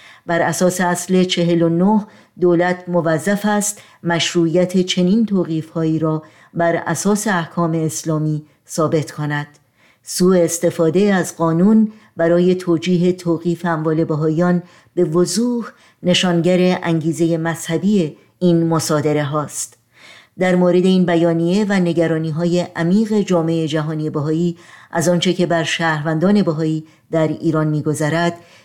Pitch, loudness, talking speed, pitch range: 170 Hz, -17 LUFS, 115 wpm, 160-180 Hz